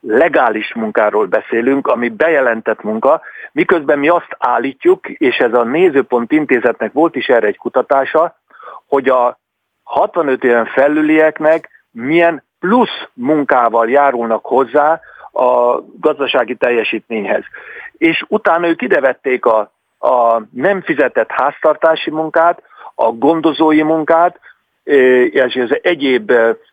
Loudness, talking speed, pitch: -13 LUFS, 110 wpm, 160 Hz